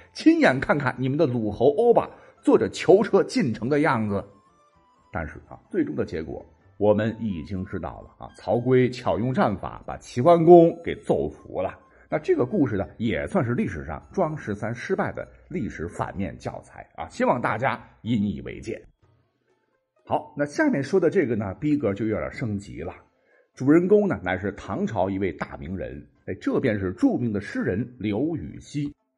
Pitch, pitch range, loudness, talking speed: 120 Hz, 100-155 Hz, -24 LUFS, 255 characters per minute